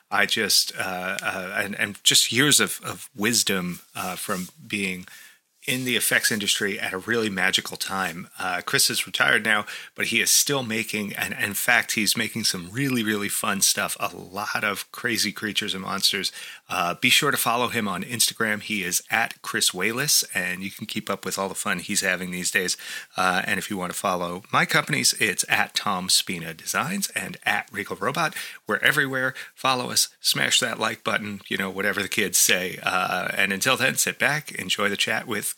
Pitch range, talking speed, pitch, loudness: 95-110 Hz, 200 wpm, 100 Hz, -23 LUFS